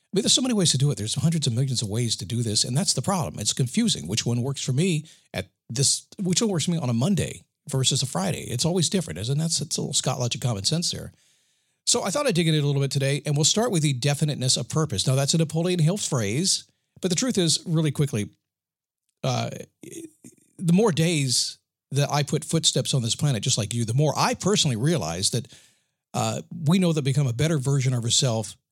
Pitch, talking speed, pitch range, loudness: 145 Hz, 245 wpm, 130-170 Hz, -23 LUFS